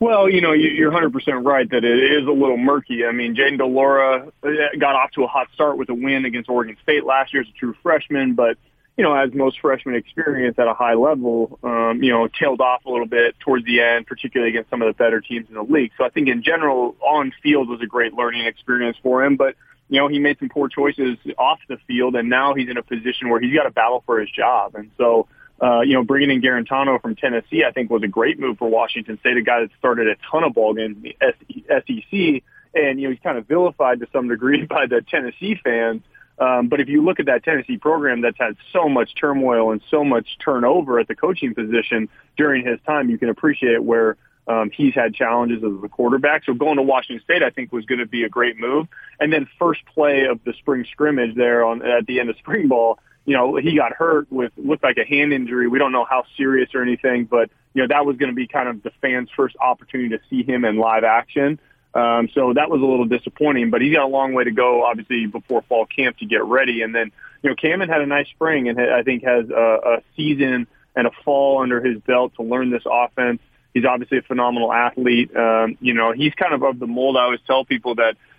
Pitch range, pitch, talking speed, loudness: 120-140 Hz, 125 Hz, 245 wpm, -18 LUFS